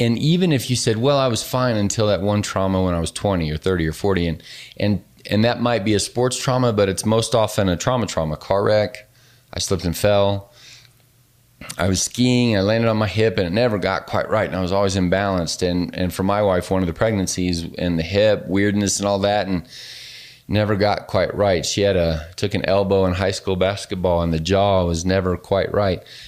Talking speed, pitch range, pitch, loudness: 230 wpm, 90-115 Hz, 100 Hz, -20 LUFS